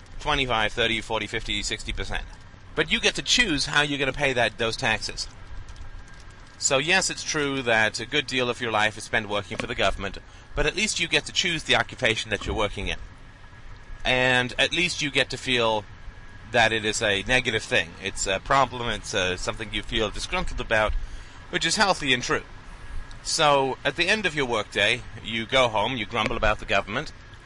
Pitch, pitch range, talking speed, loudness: 110 Hz, 100-130 Hz, 205 wpm, -24 LUFS